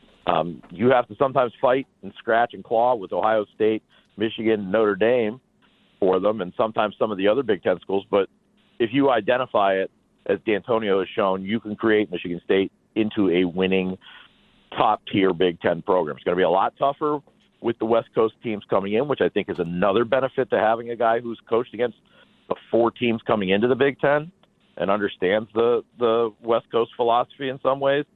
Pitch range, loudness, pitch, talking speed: 105-130 Hz, -23 LUFS, 115 Hz, 200 wpm